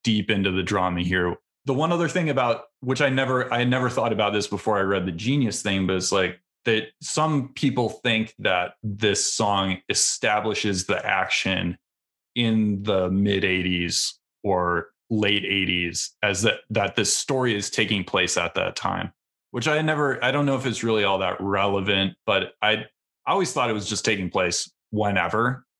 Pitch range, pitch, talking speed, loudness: 95-125 Hz, 105 Hz, 180 wpm, -23 LUFS